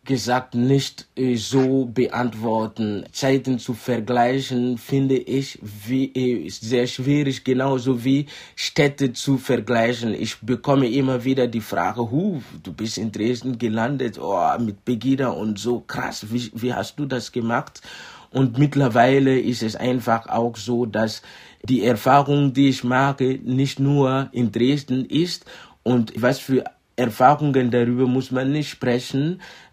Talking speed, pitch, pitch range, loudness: 135 wpm, 125 Hz, 120-135 Hz, -21 LUFS